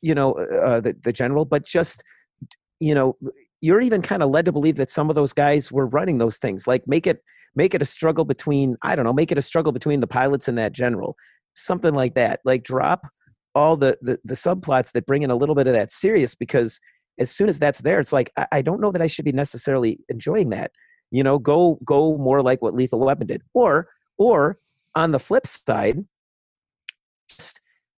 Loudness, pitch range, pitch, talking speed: -20 LUFS, 130-160 Hz, 145 Hz, 220 wpm